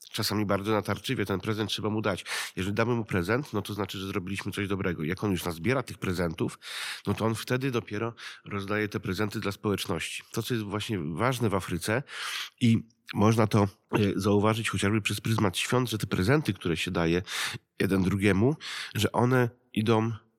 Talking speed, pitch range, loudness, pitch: 180 wpm, 100-115 Hz, -29 LUFS, 105 Hz